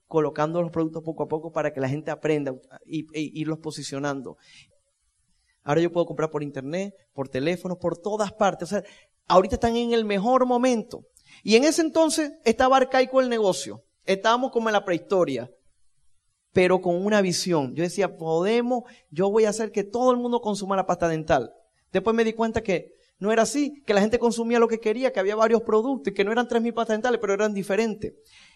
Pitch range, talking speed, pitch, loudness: 165-230 Hz, 200 wpm, 200 Hz, -24 LUFS